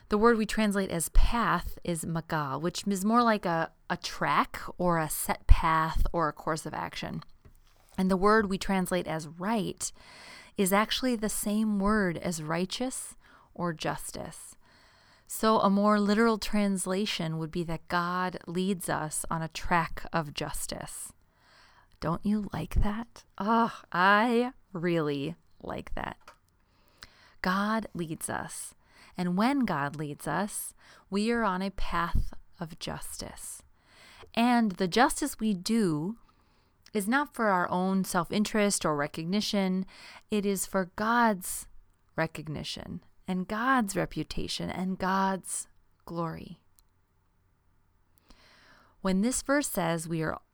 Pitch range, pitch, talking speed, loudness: 160-210 Hz, 185 Hz, 130 wpm, -30 LUFS